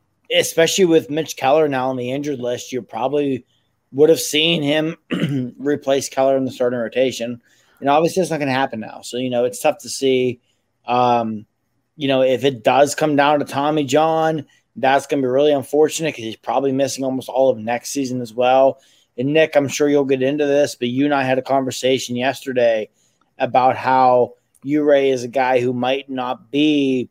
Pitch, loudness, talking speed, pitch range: 135 Hz, -18 LUFS, 200 wpm, 125-145 Hz